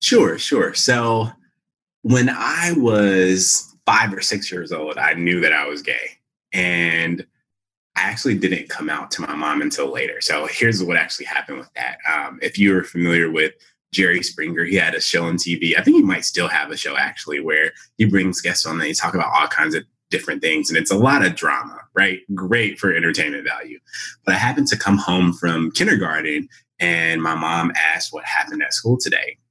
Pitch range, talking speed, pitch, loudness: 85-110 Hz, 205 wpm, 95 Hz, -18 LUFS